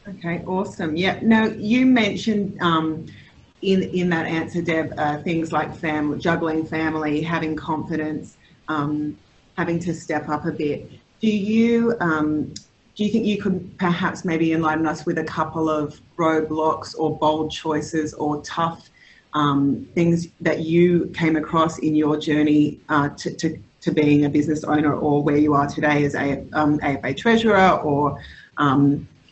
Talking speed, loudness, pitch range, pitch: 160 wpm, -21 LUFS, 150-175 Hz, 160 Hz